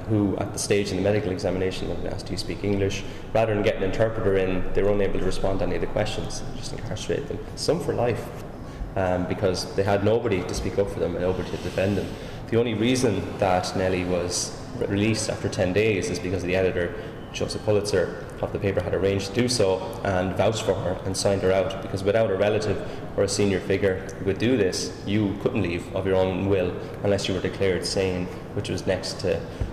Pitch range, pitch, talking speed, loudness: 95-105 Hz, 95 Hz, 230 wpm, -25 LUFS